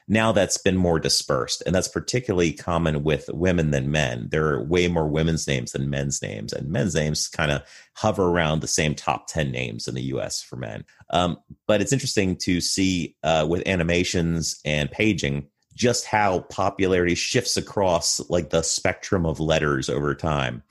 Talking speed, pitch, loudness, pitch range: 180 wpm, 80 Hz, -23 LUFS, 75-90 Hz